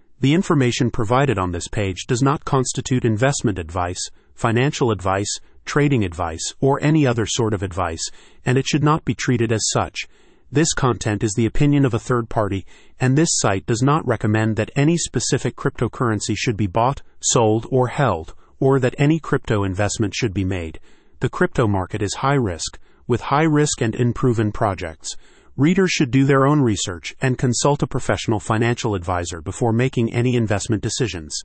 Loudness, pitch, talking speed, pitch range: -20 LUFS, 120 Hz, 175 wpm, 105-135 Hz